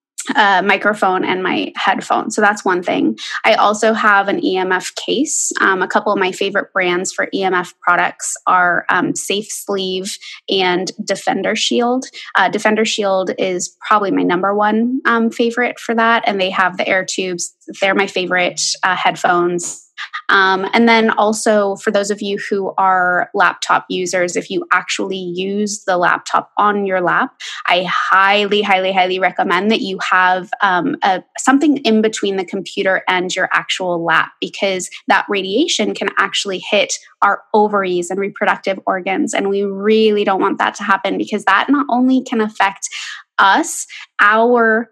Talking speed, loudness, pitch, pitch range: 160 wpm, -15 LUFS, 195 Hz, 185-215 Hz